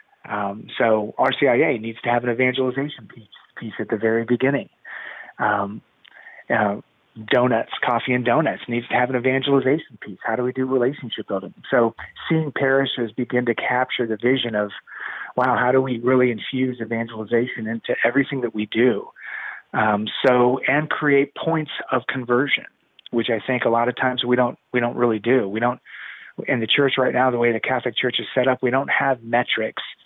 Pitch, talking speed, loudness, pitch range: 125 Hz, 185 wpm, -21 LUFS, 115-130 Hz